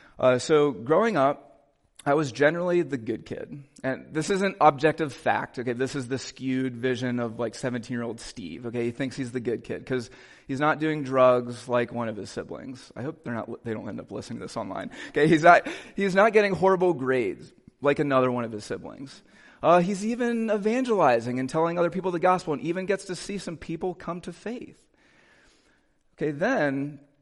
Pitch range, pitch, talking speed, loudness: 125-175 Hz, 145 Hz, 205 wpm, -26 LUFS